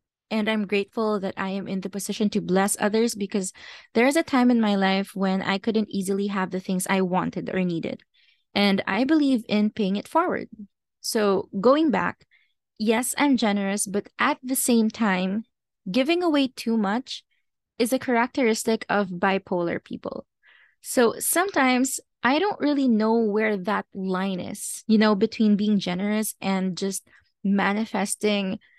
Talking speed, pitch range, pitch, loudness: 160 wpm, 195-235 Hz, 210 Hz, -24 LUFS